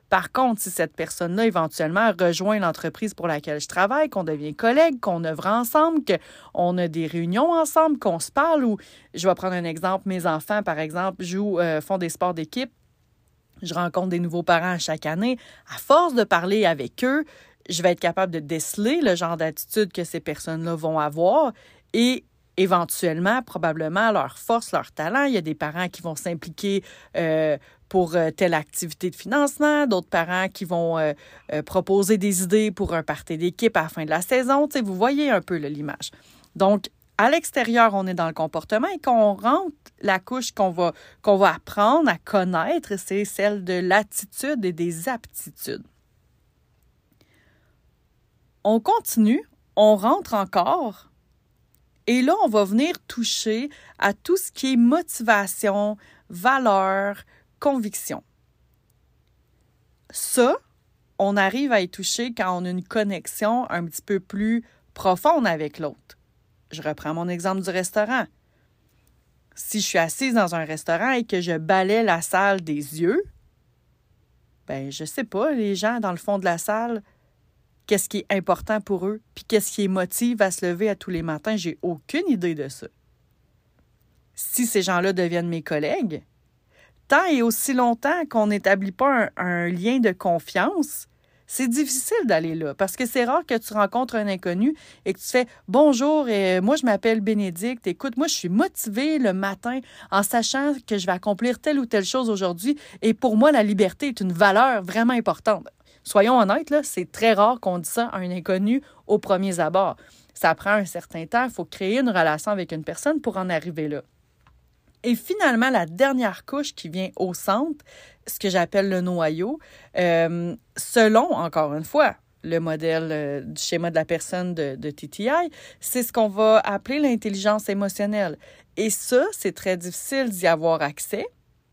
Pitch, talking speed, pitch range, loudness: 200 Hz, 175 wpm, 175-240 Hz, -23 LUFS